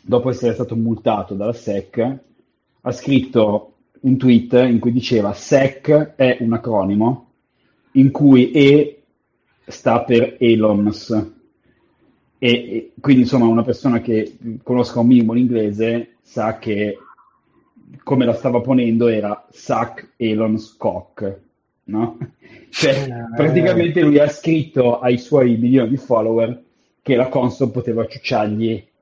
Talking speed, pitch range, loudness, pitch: 125 wpm, 115-130 Hz, -17 LUFS, 120 Hz